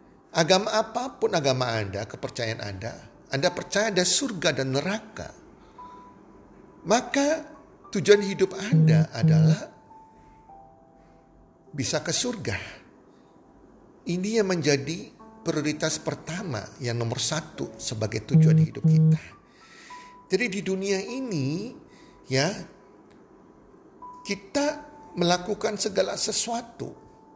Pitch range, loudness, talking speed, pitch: 155-220 Hz, -25 LUFS, 90 wpm, 180 Hz